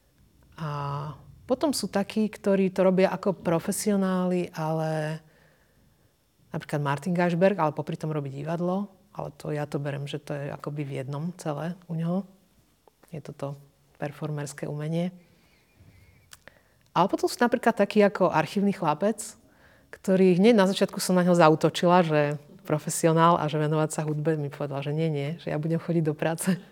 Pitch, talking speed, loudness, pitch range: 165 Hz, 155 wpm, -26 LUFS, 150-190 Hz